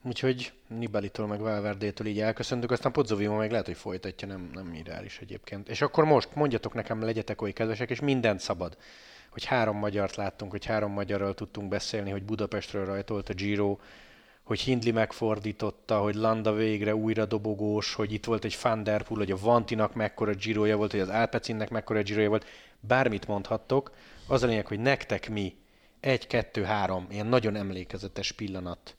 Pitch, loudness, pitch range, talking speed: 105 Hz, -30 LUFS, 105-115 Hz, 170 wpm